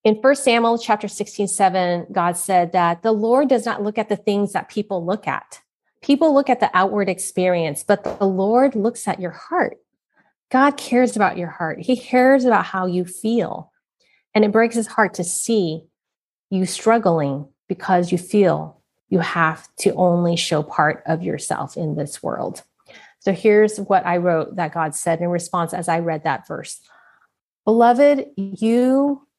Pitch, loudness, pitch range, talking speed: 195 Hz, -19 LUFS, 175-230 Hz, 175 wpm